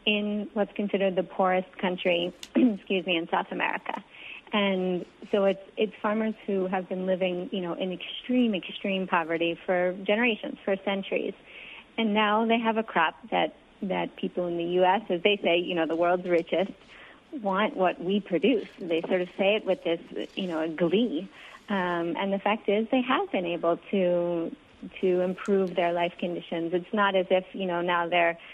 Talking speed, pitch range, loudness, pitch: 185 wpm, 175-210 Hz, -27 LUFS, 190 Hz